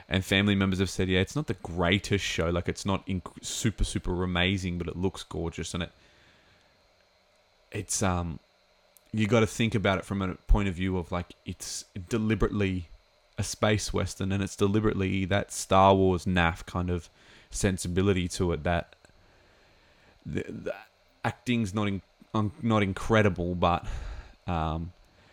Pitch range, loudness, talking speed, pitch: 90-100 Hz, -28 LUFS, 160 wpm, 95 Hz